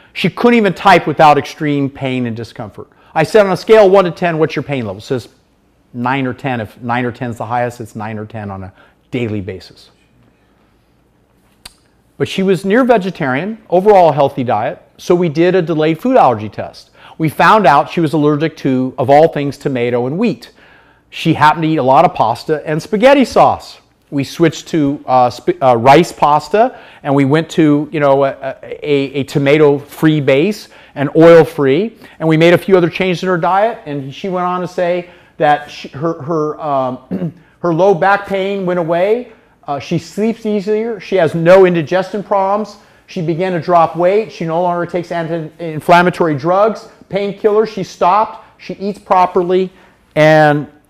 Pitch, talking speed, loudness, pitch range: 165 Hz, 185 wpm, -13 LUFS, 140-185 Hz